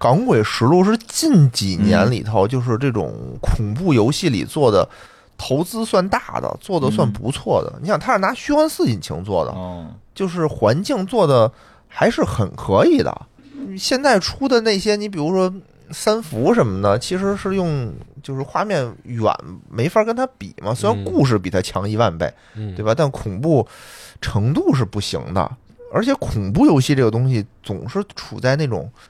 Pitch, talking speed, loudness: 140 Hz, 255 characters per minute, -18 LUFS